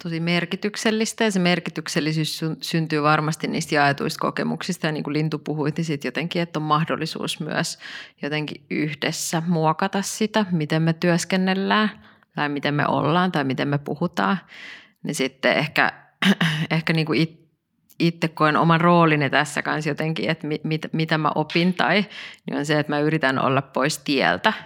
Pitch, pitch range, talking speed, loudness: 160 Hz, 150-175 Hz, 160 wpm, -22 LUFS